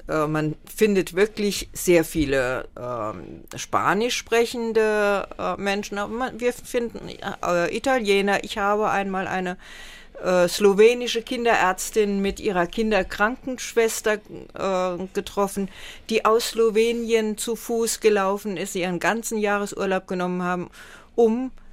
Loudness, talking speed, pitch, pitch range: -23 LUFS, 115 wpm, 205 Hz, 185-225 Hz